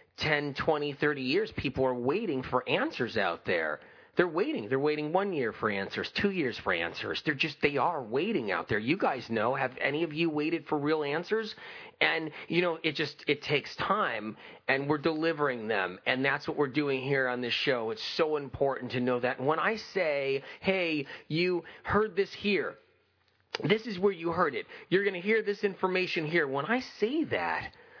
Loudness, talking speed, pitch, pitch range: -30 LUFS, 200 wpm, 160 Hz, 140-200 Hz